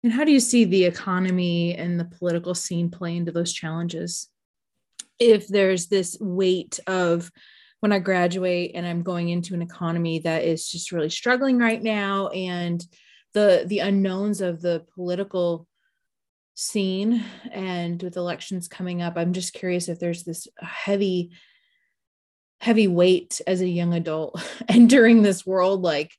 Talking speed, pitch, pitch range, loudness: 150 wpm, 180 Hz, 170-200 Hz, -23 LUFS